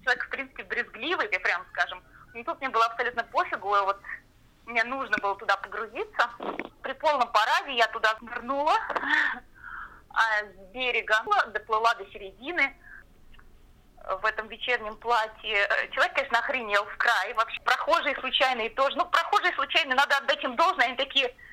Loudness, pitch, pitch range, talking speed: -26 LUFS, 245 Hz, 220-280 Hz, 150 wpm